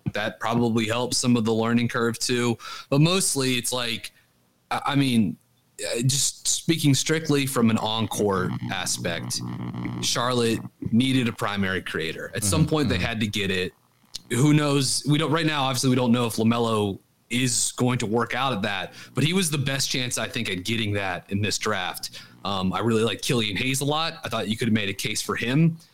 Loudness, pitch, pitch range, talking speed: -24 LUFS, 120 Hz, 105-135 Hz, 200 wpm